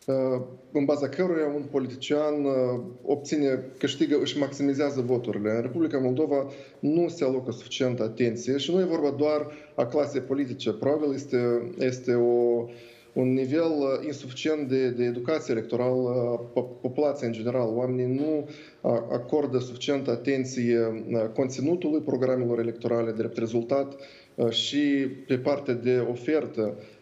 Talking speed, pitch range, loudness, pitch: 125 wpm, 120-145 Hz, -27 LUFS, 130 Hz